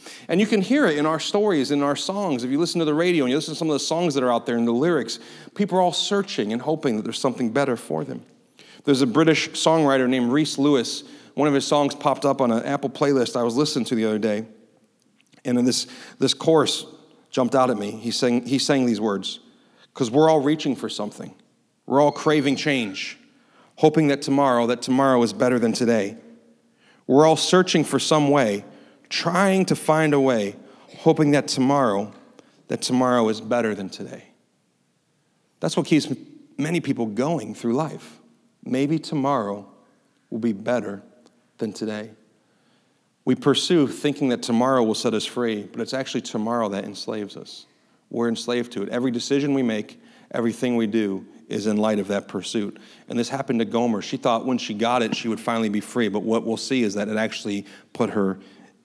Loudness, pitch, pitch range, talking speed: -22 LUFS, 130 Hz, 115-155 Hz, 200 wpm